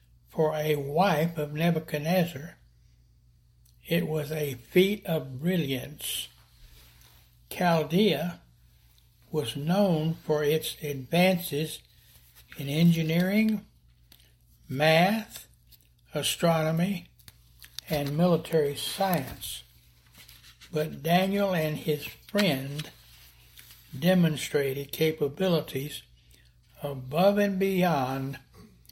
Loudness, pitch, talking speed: -27 LUFS, 150 Hz, 70 wpm